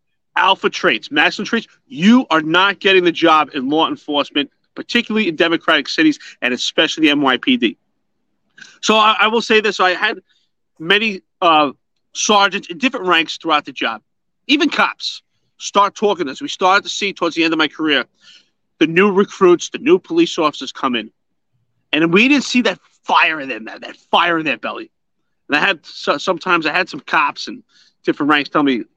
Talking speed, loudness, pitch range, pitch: 185 wpm, -15 LUFS, 165-255 Hz, 200 Hz